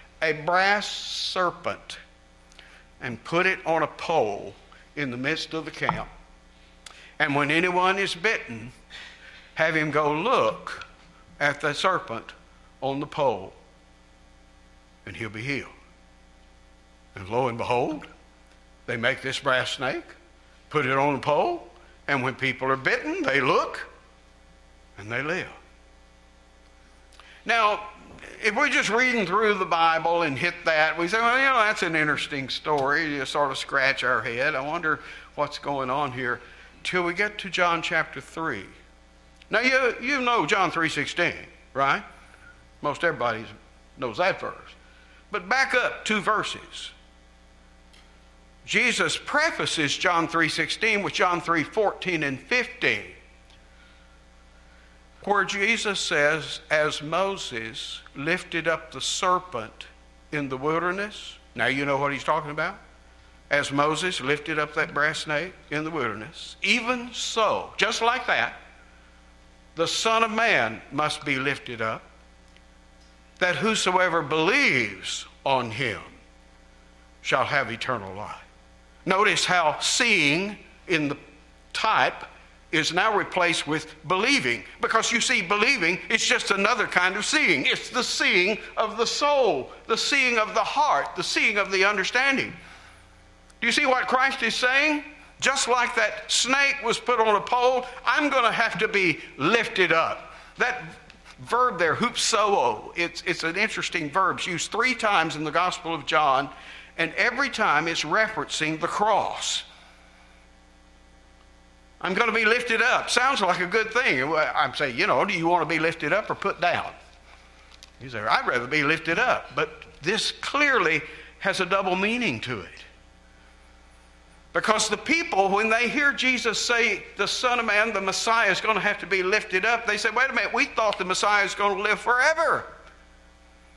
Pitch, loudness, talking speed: 155 Hz, -23 LUFS, 150 wpm